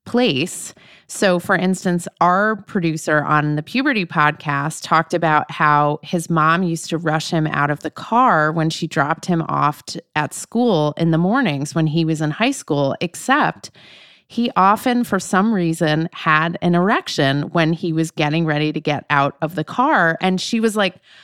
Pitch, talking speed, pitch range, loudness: 165 Hz, 180 wpm, 150-185 Hz, -18 LUFS